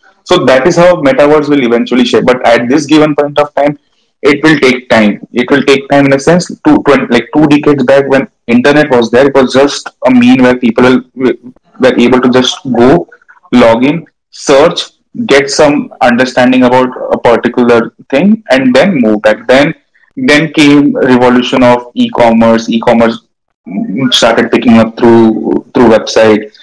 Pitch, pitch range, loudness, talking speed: 130 Hz, 120-145 Hz, -7 LUFS, 165 wpm